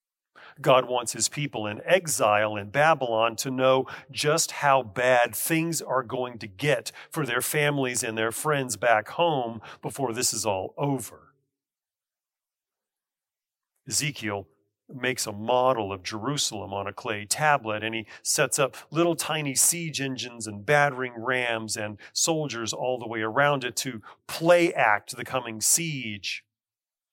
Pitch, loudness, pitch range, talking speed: 125 Hz, -25 LUFS, 110-140 Hz, 145 wpm